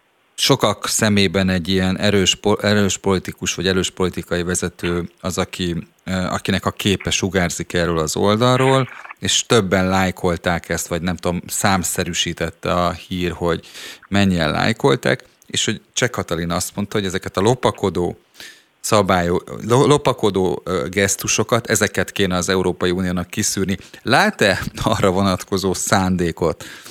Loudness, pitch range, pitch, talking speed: -19 LUFS, 90-100 Hz, 95 Hz, 125 wpm